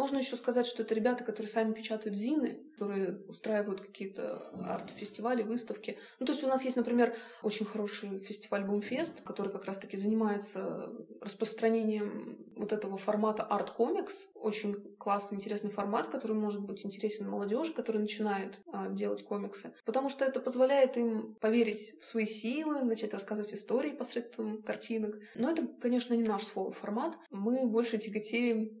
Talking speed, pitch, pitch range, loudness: 150 wpm, 220 Hz, 205-240 Hz, -34 LUFS